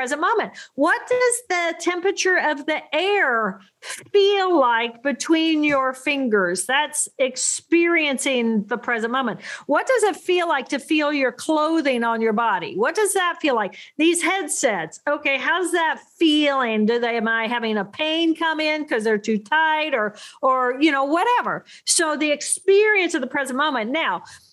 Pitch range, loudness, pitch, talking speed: 255-345 Hz, -20 LUFS, 300 Hz, 165 wpm